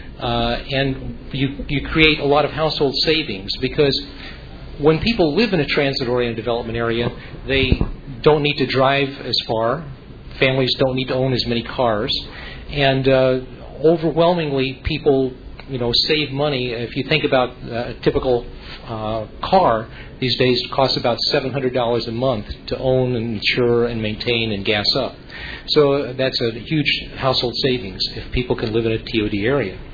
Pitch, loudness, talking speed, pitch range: 130 Hz, -19 LUFS, 160 wpm, 120-140 Hz